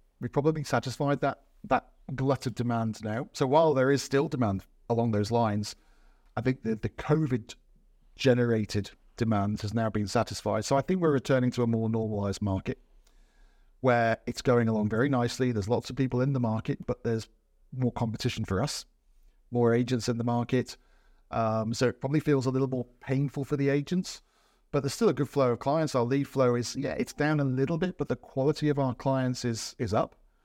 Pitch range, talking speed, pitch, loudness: 115-140 Hz, 200 wpm, 125 Hz, -29 LUFS